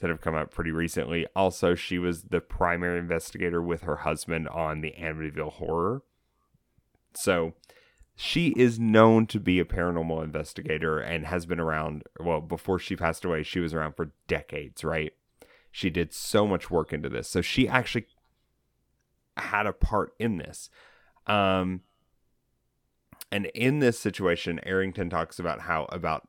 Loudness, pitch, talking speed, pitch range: -28 LUFS, 85 Hz, 155 wpm, 80-95 Hz